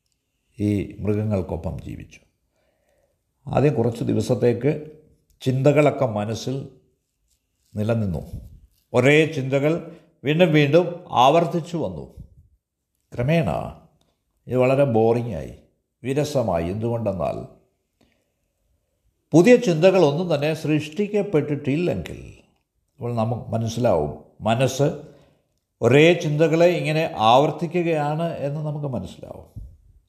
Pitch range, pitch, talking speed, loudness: 105-155 Hz, 130 Hz, 70 wpm, -21 LUFS